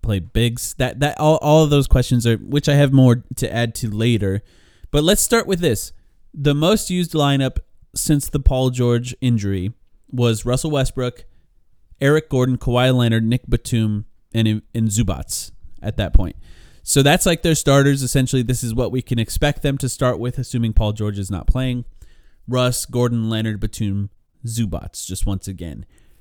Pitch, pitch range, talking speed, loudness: 120 Hz, 105-135 Hz, 175 wpm, -19 LUFS